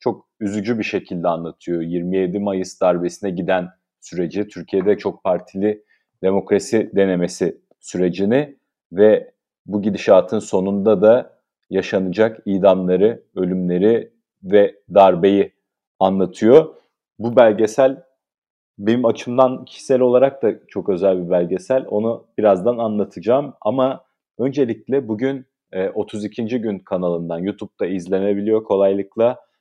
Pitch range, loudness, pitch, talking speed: 95-115 Hz, -18 LUFS, 105 Hz, 100 wpm